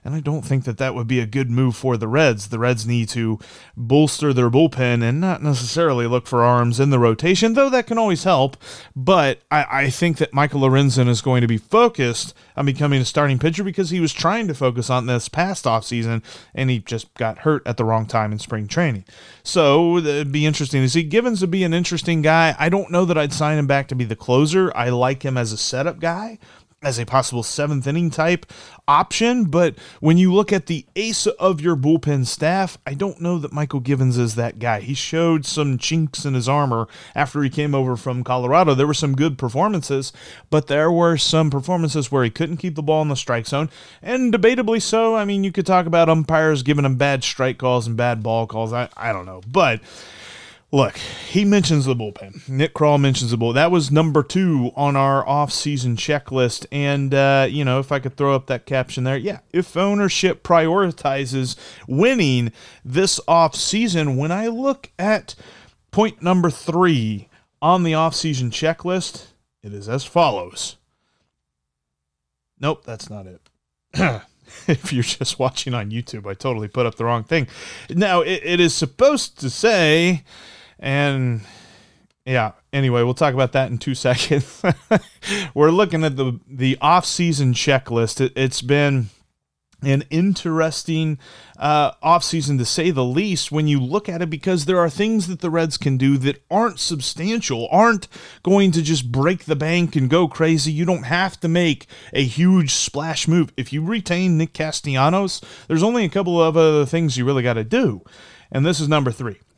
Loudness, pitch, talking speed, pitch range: -19 LUFS, 145 Hz, 195 wpm, 125-170 Hz